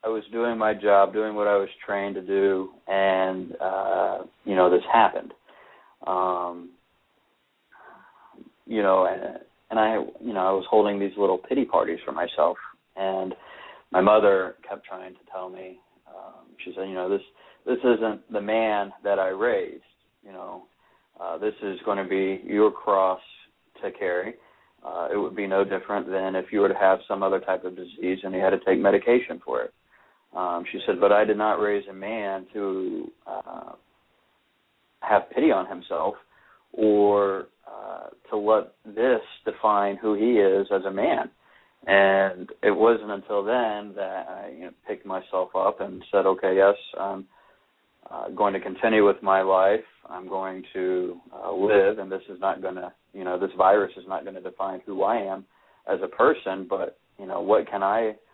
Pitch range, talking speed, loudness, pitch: 95-105 Hz, 180 wpm, -24 LUFS, 95 Hz